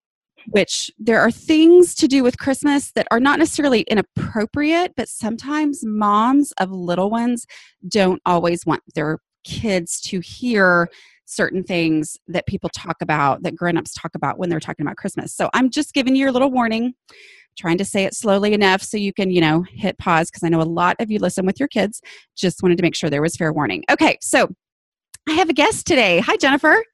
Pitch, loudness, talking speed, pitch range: 210 Hz, -18 LUFS, 205 wpm, 175-270 Hz